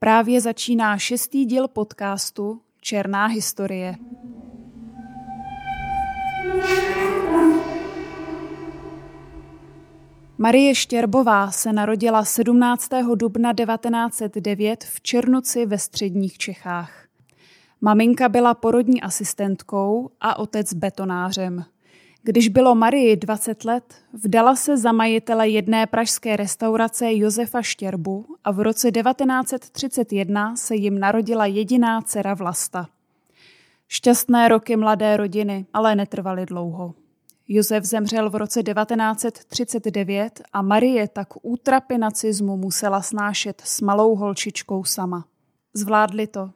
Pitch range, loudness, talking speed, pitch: 200-240 Hz, -20 LUFS, 95 wpm, 220 Hz